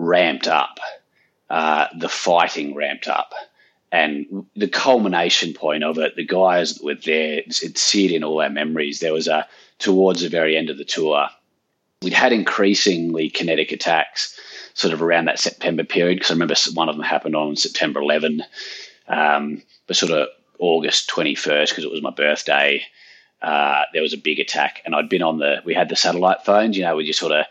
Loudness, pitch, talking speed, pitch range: -19 LUFS, 80 Hz, 190 wpm, 75-95 Hz